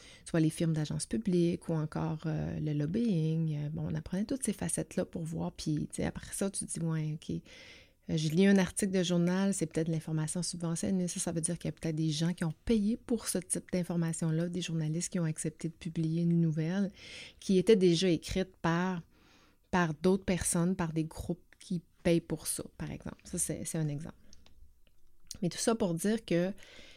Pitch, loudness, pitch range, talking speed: 170 Hz, -33 LUFS, 160-185 Hz, 205 wpm